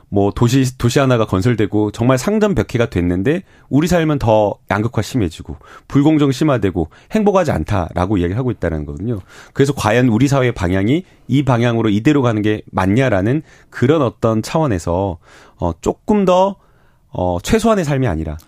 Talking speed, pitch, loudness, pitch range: 365 characters per minute, 120 Hz, -16 LUFS, 100-140 Hz